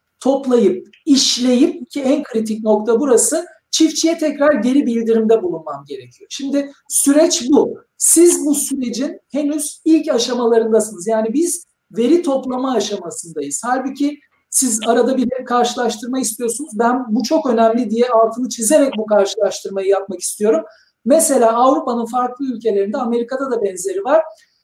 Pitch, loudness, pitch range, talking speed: 255 Hz, -16 LUFS, 225-295 Hz, 125 wpm